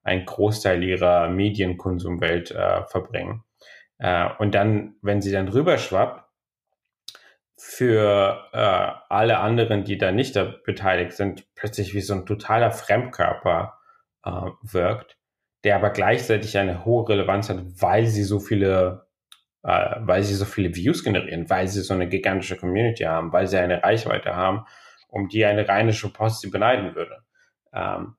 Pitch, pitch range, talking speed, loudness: 100 Hz, 95-105 Hz, 150 wpm, -22 LUFS